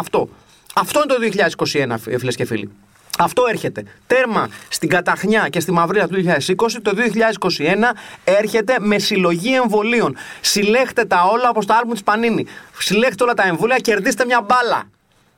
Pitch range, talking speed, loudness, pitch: 170-240 Hz, 150 wpm, -17 LUFS, 210 Hz